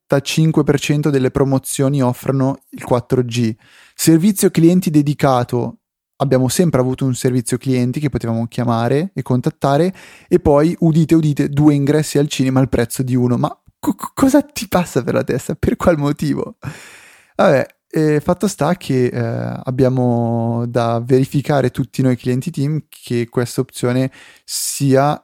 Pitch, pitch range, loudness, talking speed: 135 Hz, 125-150 Hz, -16 LUFS, 145 wpm